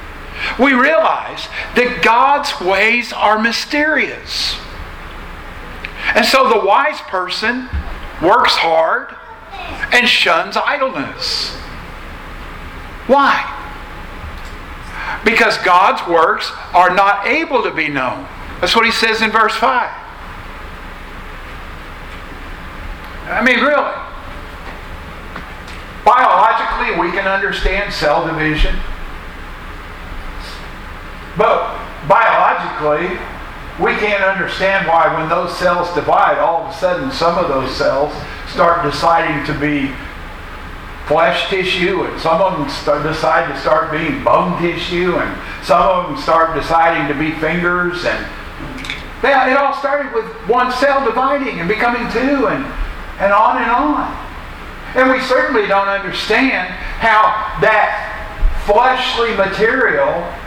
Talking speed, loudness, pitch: 110 wpm, -14 LUFS, 165 Hz